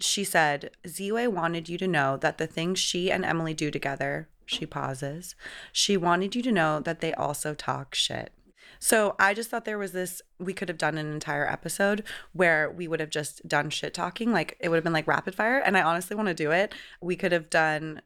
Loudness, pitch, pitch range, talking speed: -27 LUFS, 170 Hz, 155-195 Hz, 225 wpm